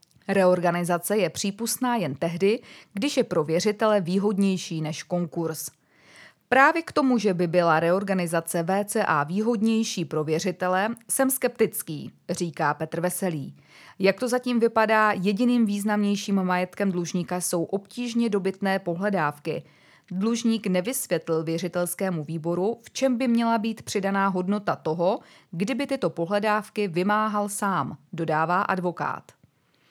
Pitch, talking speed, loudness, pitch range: 195 Hz, 120 wpm, -25 LUFS, 170-215 Hz